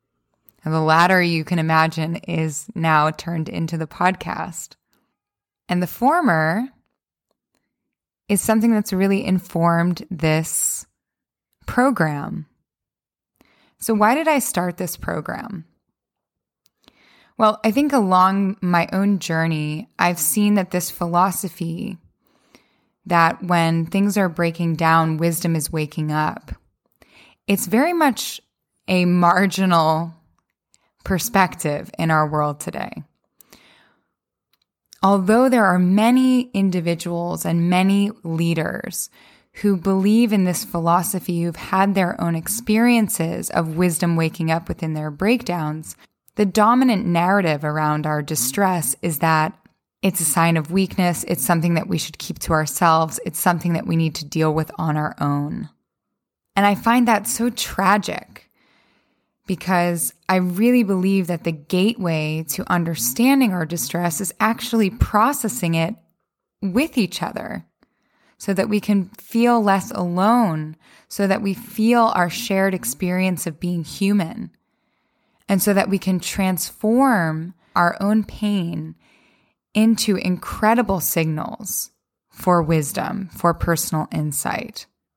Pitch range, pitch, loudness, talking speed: 165-205 Hz, 180 Hz, -20 LUFS, 125 wpm